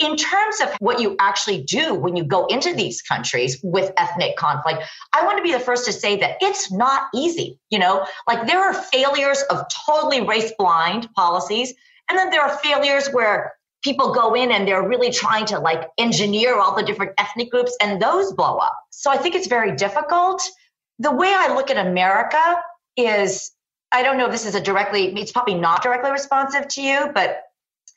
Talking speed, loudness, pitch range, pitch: 200 wpm, -19 LUFS, 200-295 Hz, 245 Hz